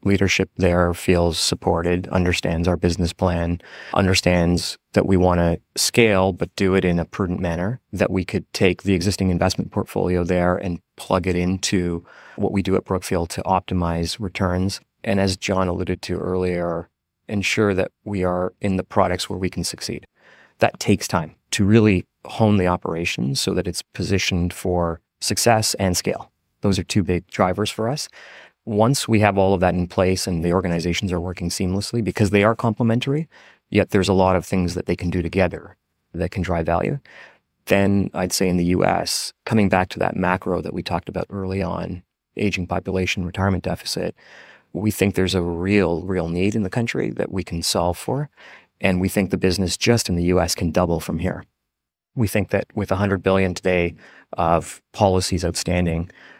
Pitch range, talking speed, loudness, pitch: 90-100 Hz, 185 wpm, -21 LUFS, 95 Hz